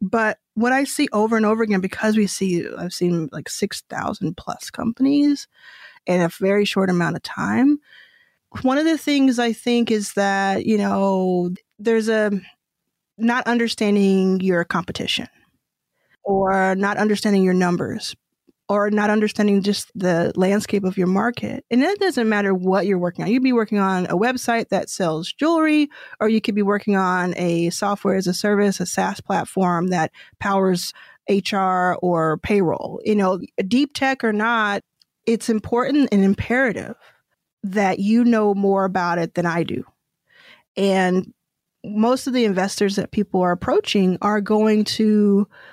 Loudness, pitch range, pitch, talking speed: -20 LUFS, 190-230 Hz, 205 Hz, 160 wpm